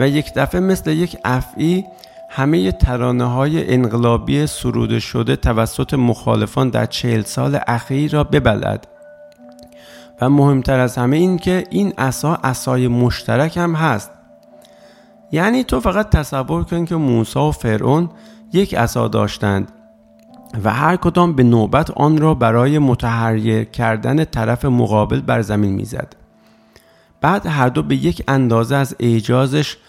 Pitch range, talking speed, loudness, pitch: 115-155 Hz, 135 wpm, -16 LUFS, 125 Hz